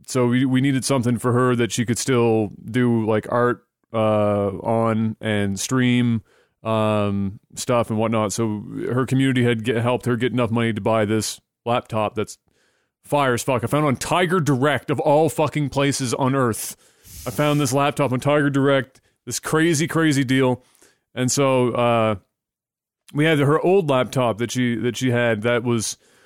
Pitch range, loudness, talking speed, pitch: 115-135 Hz, -20 LUFS, 180 wpm, 125 Hz